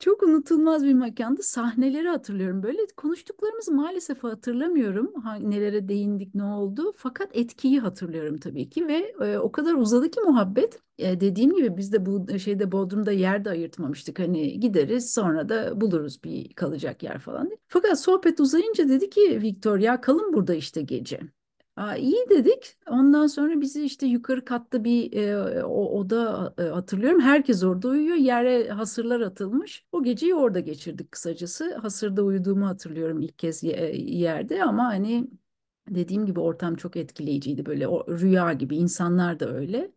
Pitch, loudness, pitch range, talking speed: 235 Hz, -24 LUFS, 190-290 Hz, 155 wpm